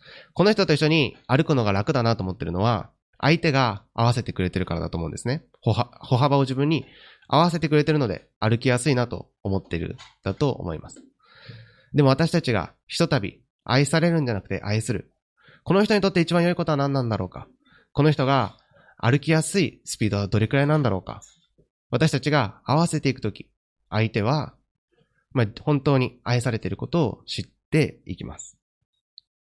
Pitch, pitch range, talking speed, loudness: 130 Hz, 110-155 Hz, 370 characters per minute, -23 LUFS